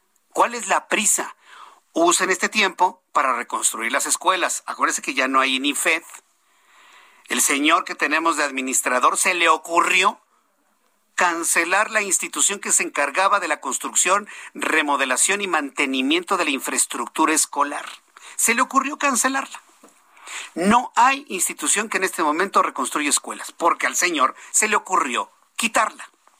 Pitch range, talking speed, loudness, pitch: 150-220 Hz, 145 wpm, -19 LUFS, 180 Hz